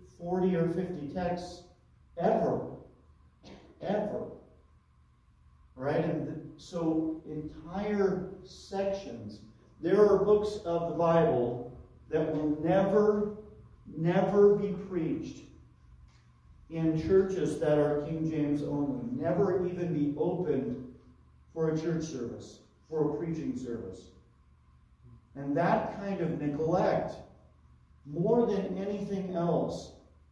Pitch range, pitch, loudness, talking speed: 115-185 Hz, 160 Hz, -30 LUFS, 105 wpm